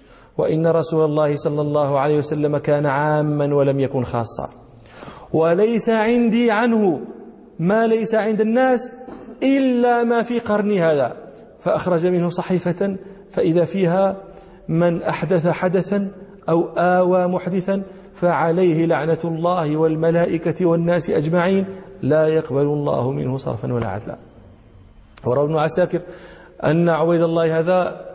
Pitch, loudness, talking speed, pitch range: 175 Hz, -19 LUFS, 115 wpm, 155-195 Hz